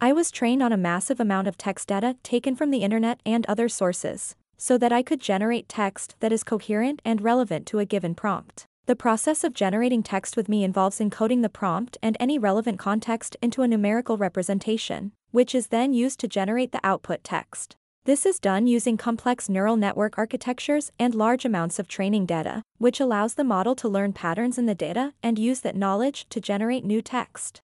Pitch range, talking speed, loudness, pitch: 200-245 Hz, 200 wpm, -25 LUFS, 225 Hz